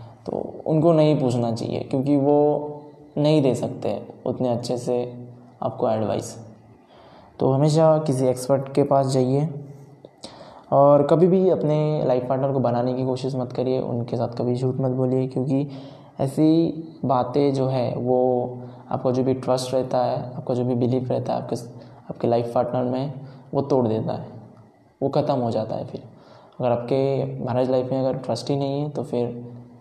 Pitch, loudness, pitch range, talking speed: 130 Hz, -22 LUFS, 125-140 Hz, 170 wpm